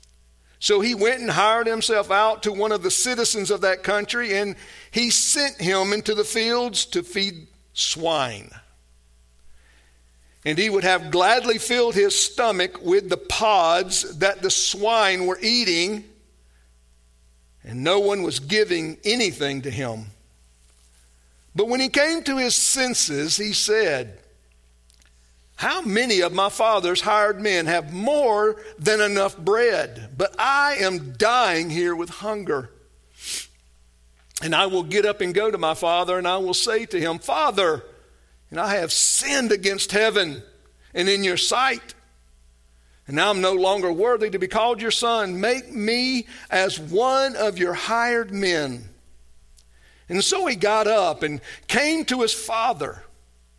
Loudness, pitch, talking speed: -21 LUFS, 190 Hz, 150 wpm